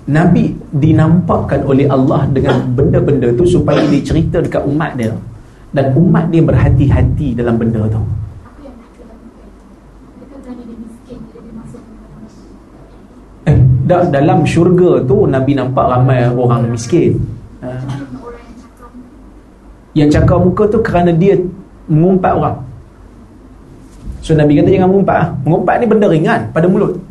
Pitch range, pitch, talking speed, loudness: 130-180 Hz, 150 Hz, 110 wpm, -11 LUFS